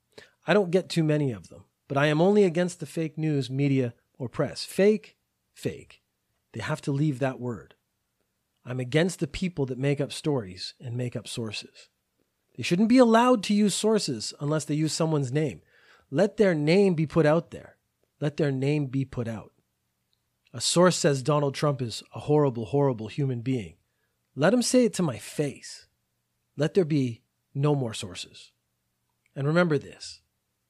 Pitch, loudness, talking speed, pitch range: 145 Hz, -26 LUFS, 175 wpm, 120-165 Hz